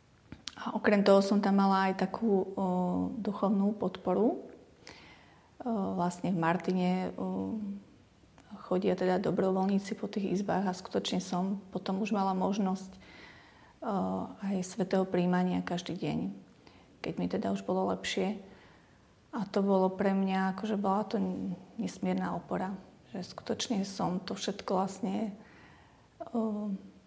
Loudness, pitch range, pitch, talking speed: -32 LUFS, 185-205 Hz, 195 Hz, 130 wpm